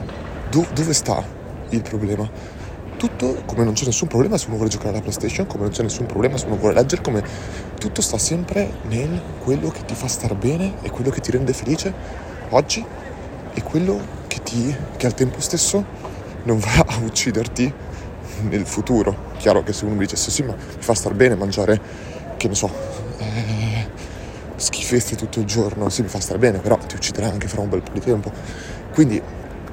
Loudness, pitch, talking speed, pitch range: -21 LUFS, 110 Hz, 190 wpm, 100-125 Hz